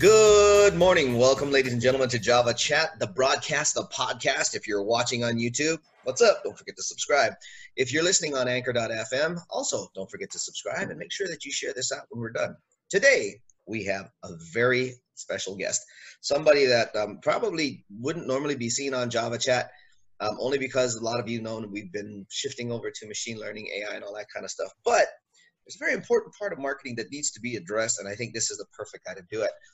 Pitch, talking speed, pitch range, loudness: 125 Hz, 220 wpm, 115-165 Hz, -26 LUFS